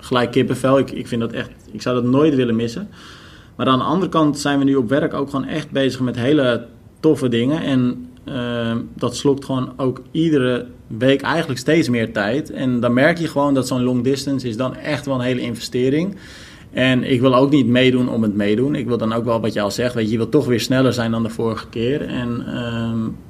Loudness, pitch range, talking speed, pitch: -19 LUFS, 115-135 Hz, 235 wpm, 125 Hz